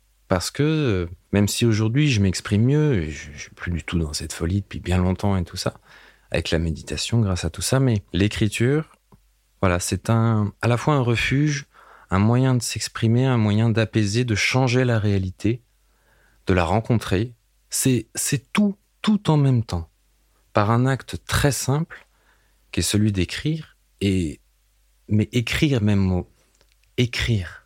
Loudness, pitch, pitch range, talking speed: -22 LUFS, 110 Hz, 95-125 Hz, 165 wpm